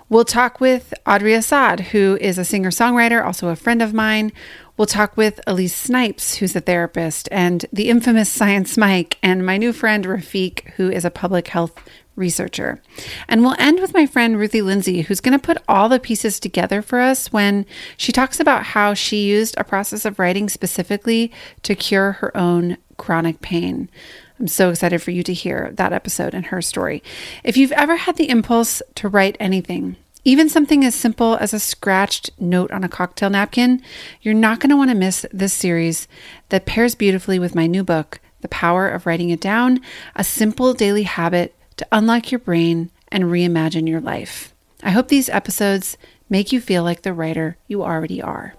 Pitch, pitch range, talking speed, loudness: 205 Hz, 180-235 Hz, 190 wpm, -17 LUFS